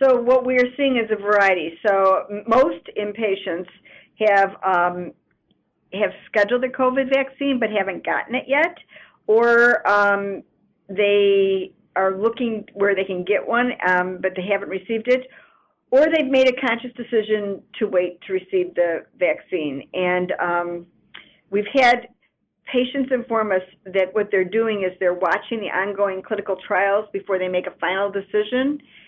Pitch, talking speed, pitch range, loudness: 205 Hz, 155 wpm, 190-240 Hz, -20 LUFS